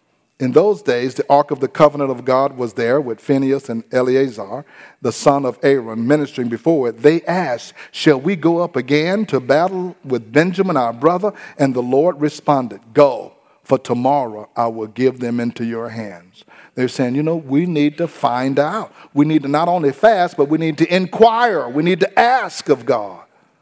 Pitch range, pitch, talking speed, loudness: 125-165 Hz, 140 Hz, 195 wpm, -17 LUFS